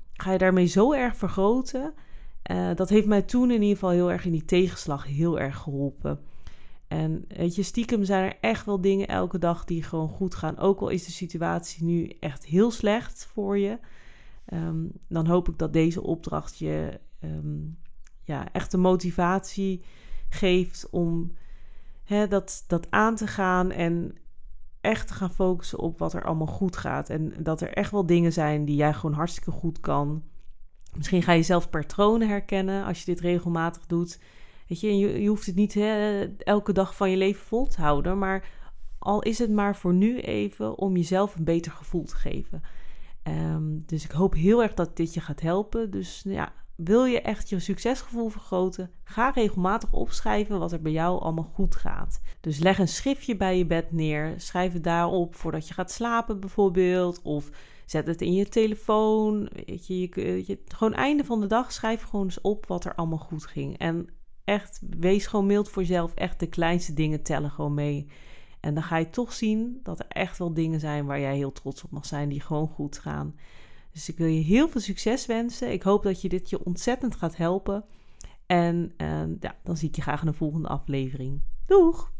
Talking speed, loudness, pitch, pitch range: 200 wpm, -27 LUFS, 175 Hz, 155-200 Hz